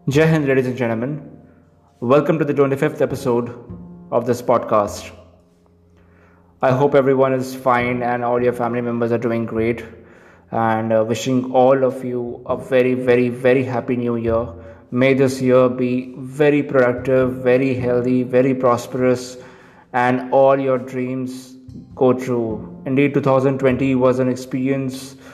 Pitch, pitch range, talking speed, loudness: 125 Hz, 120-130 Hz, 140 wpm, -18 LUFS